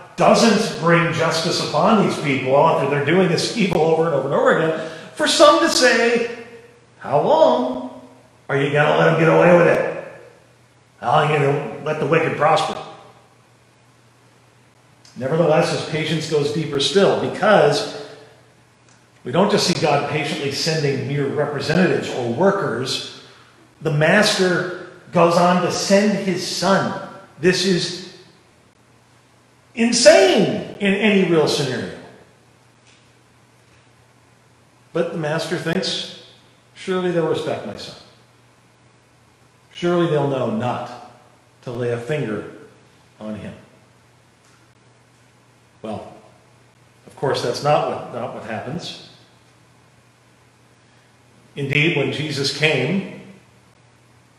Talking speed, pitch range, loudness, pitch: 120 wpm, 135-185 Hz, -18 LUFS, 160 Hz